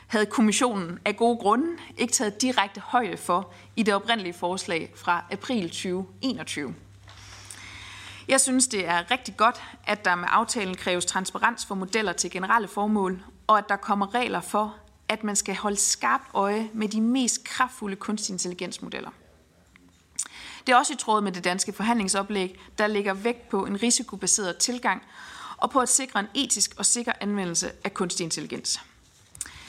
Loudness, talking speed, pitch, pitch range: -25 LUFS, 160 wpm, 205 Hz, 180-230 Hz